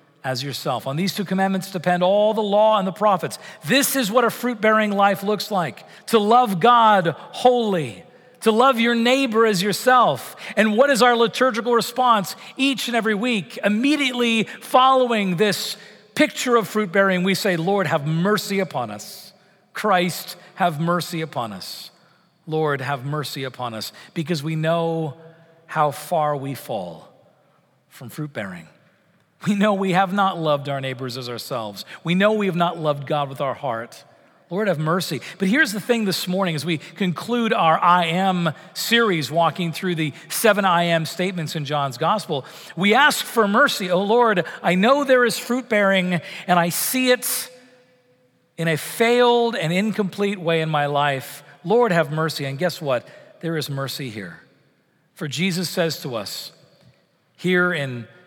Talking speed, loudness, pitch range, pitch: 170 wpm, -20 LUFS, 160-215 Hz, 185 Hz